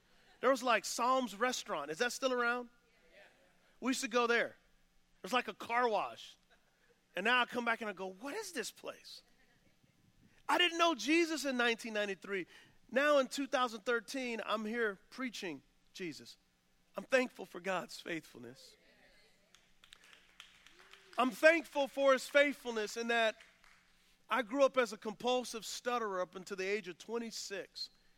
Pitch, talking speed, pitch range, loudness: 240 Hz, 150 wpm, 210-260 Hz, -35 LUFS